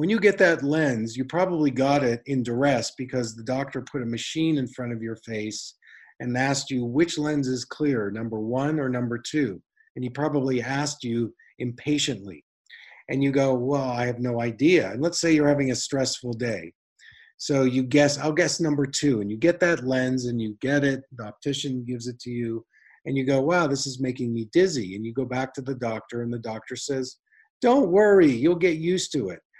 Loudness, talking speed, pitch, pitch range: -25 LUFS, 215 wpm, 130 Hz, 120-145 Hz